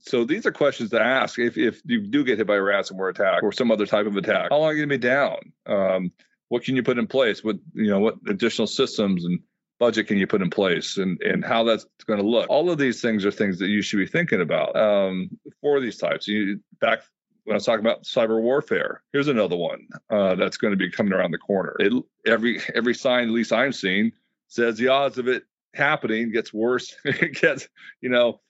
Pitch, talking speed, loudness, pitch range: 115 Hz, 240 wpm, -23 LUFS, 105-125 Hz